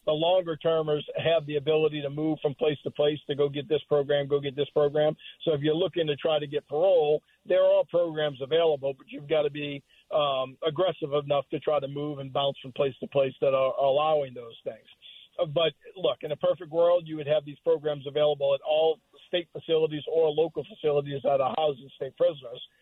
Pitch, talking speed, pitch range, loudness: 150 Hz, 215 wpm, 145-160 Hz, -27 LUFS